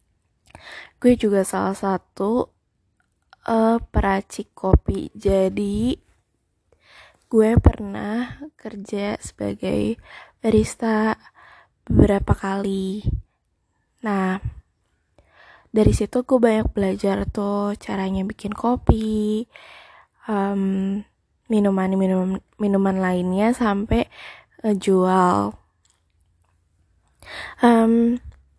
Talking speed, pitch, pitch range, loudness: 70 wpm, 200 Hz, 190-220 Hz, -21 LUFS